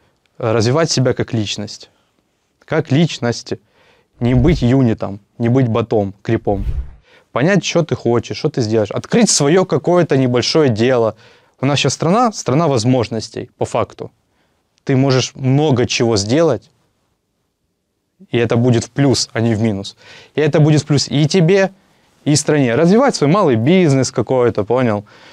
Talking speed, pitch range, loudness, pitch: 145 wpm, 115-150 Hz, -15 LUFS, 125 Hz